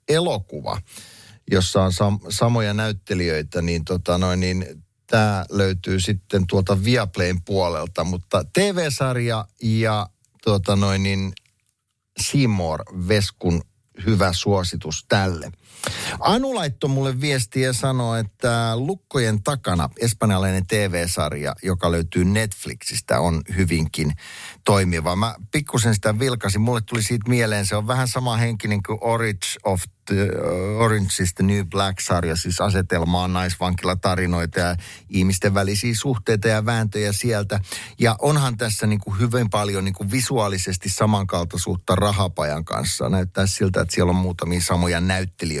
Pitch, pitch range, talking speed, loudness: 100 Hz, 90-115 Hz, 125 wpm, -21 LUFS